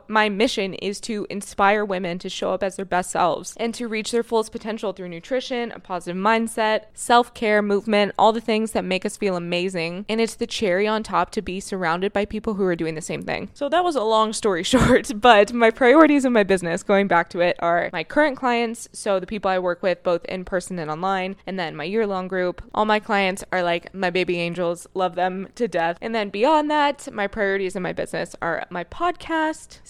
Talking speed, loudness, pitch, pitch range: 230 wpm, -22 LUFS, 200 Hz, 185-225 Hz